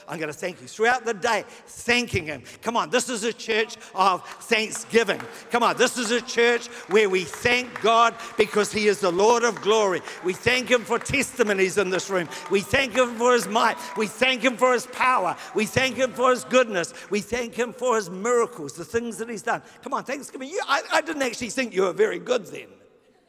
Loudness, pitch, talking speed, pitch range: -23 LUFS, 230 Hz, 215 wpm, 205-245 Hz